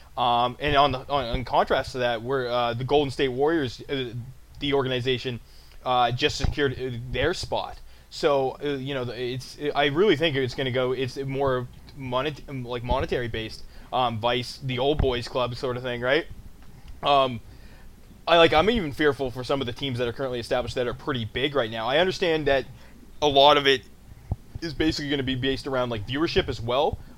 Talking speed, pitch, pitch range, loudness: 200 wpm, 130 Hz, 125-140 Hz, -25 LUFS